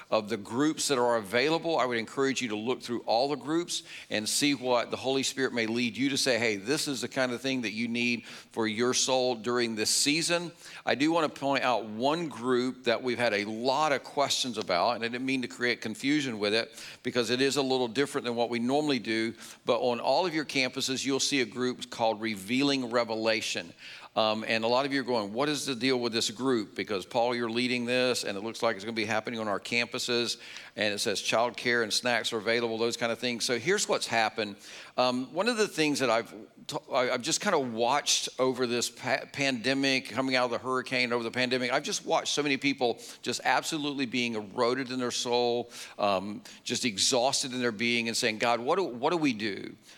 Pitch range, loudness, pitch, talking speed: 115-135 Hz, -29 LUFS, 125 Hz, 235 wpm